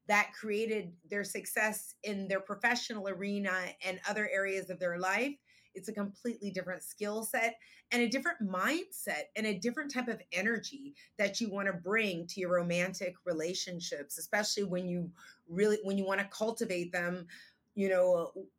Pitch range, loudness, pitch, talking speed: 185-220 Hz, -34 LUFS, 200 Hz, 165 wpm